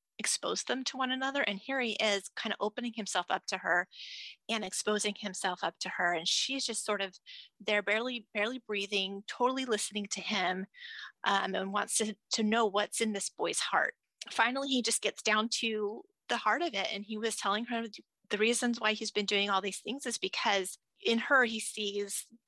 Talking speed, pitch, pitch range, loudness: 205 wpm, 215 Hz, 200-230 Hz, -32 LUFS